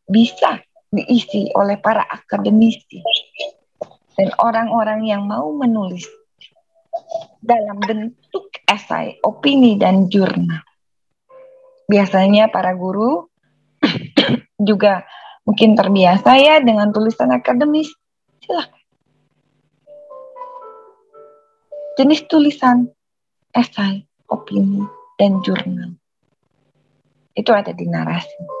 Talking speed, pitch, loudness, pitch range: 80 wpm, 220 Hz, -16 LUFS, 195-295 Hz